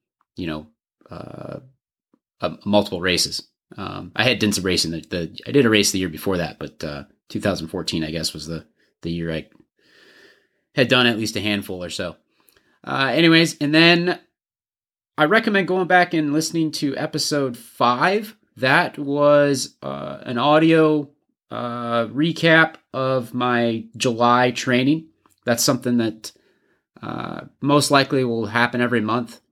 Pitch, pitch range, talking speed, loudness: 125 Hz, 105-150 Hz, 150 wpm, -20 LUFS